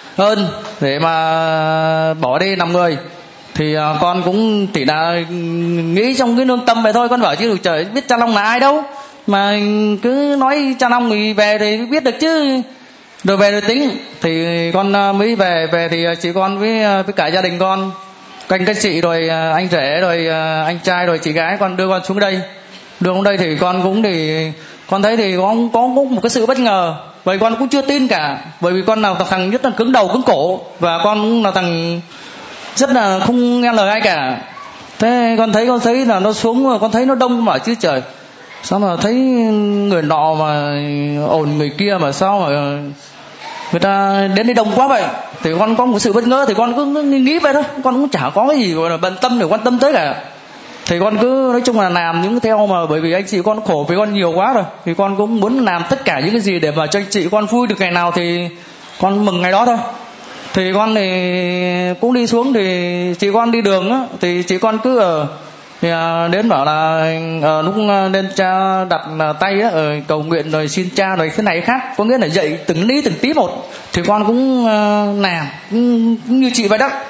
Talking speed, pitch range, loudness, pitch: 220 wpm, 170-235 Hz, -14 LUFS, 200 Hz